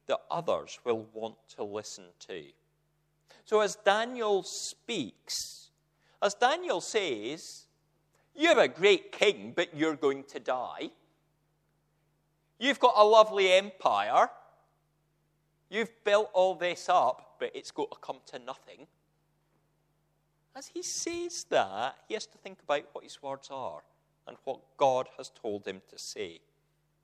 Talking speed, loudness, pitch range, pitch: 135 wpm, -29 LUFS, 155-230 Hz, 180 Hz